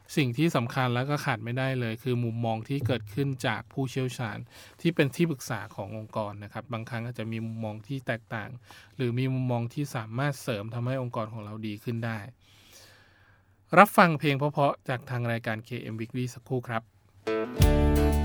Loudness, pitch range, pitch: -29 LUFS, 110-130 Hz, 120 Hz